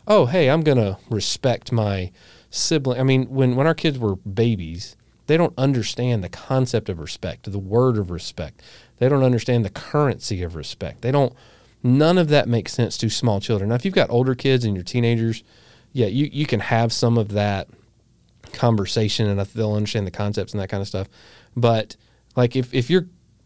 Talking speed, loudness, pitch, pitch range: 195 wpm, -21 LUFS, 115 Hz, 105-130 Hz